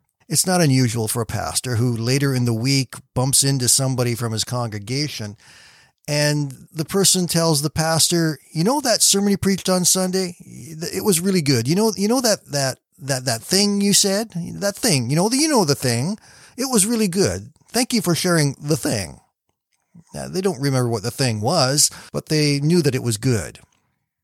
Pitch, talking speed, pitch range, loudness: 150 Hz, 200 wpm, 130-185 Hz, -19 LUFS